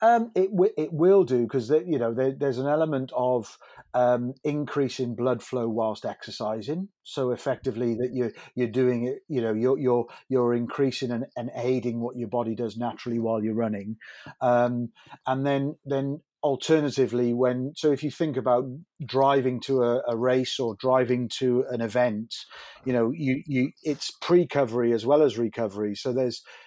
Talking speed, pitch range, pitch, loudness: 175 wpm, 120-140 Hz, 125 Hz, -26 LUFS